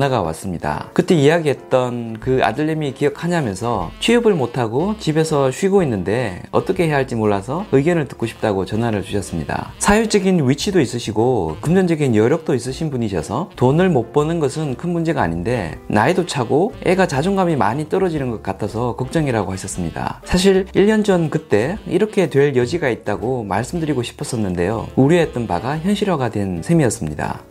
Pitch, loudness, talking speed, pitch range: 135 Hz, -18 LUFS, 385 characters per minute, 110-170 Hz